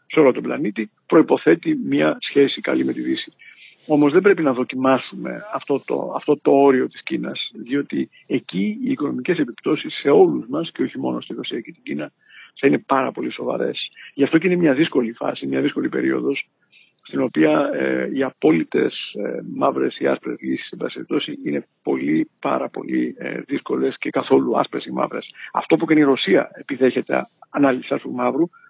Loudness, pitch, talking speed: -20 LUFS, 140 Hz, 180 wpm